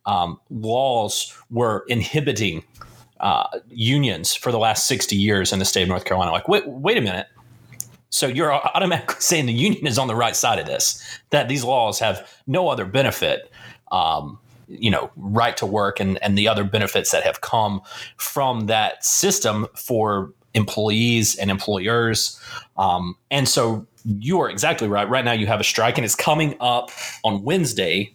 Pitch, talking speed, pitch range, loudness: 115 Hz, 175 wpm, 105-120 Hz, -20 LUFS